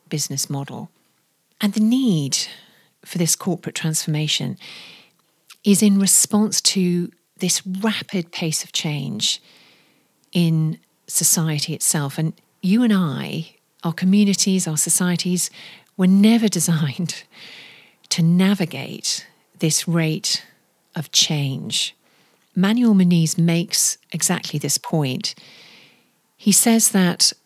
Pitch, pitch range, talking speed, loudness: 175 Hz, 160-195 Hz, 105 wpm, -19 LUFS